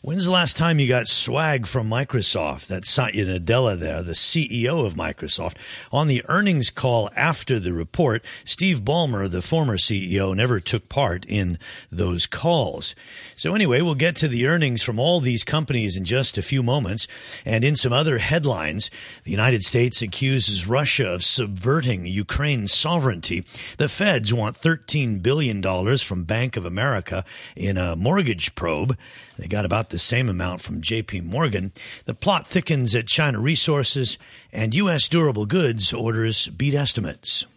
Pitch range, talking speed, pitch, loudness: 100-145 Hz, 160 wpm, 120 Hz, -21 LUFS